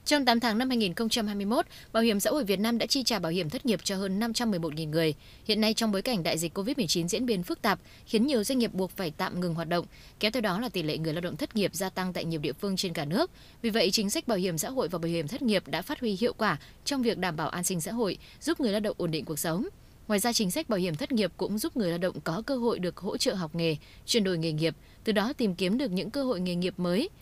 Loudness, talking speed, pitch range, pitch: -29 LUFS, 295 wpm, 175-235 Hz, 200 Hz